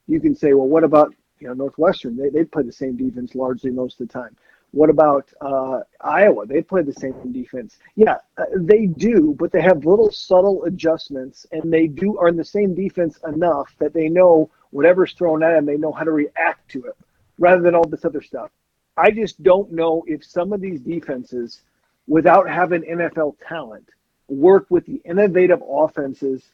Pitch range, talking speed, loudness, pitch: 140-185 Hz, 190 wpm, -18 LUFS, 160 Hz